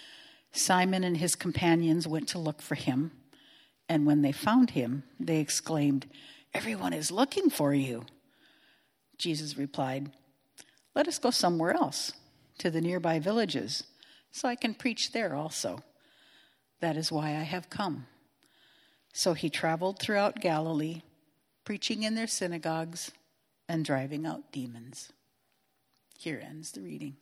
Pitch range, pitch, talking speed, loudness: 150-205 Hz, 165 Hz, 135 wpm, -31 LUFS